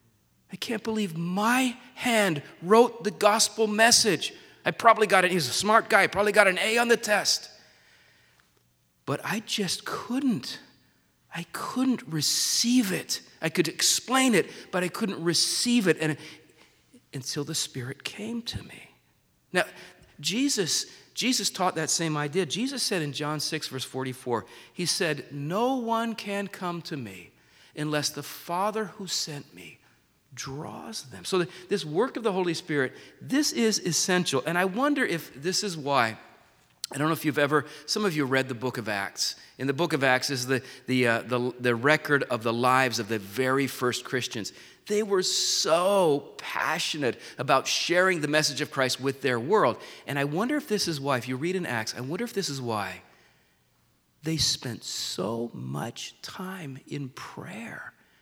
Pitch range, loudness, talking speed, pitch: 135-205 Hz, -26 LUFS, 175 wpm, 160 Hz